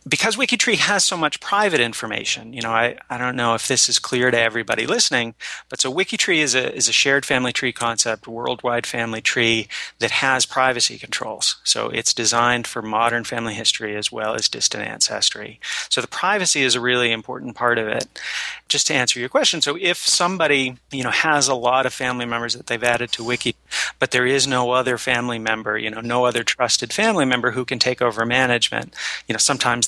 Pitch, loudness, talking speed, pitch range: 125 Hz, -19 LUFS, 205 wpm, 115-135 Hz